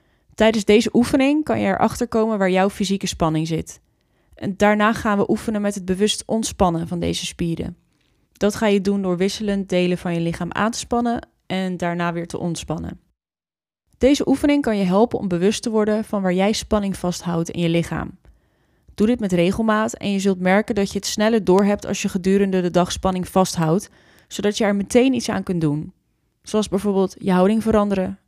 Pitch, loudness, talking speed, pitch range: 200 Hz, -20 LUFS, 195 wpm, 180-215 Hz